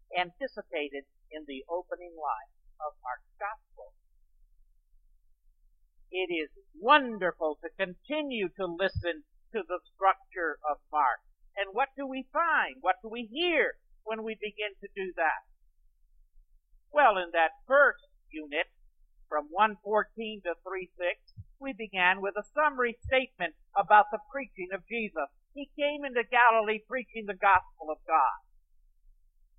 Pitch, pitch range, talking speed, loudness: 185 Hz, 140-230 Hz, 130 wpm, -30 LUFS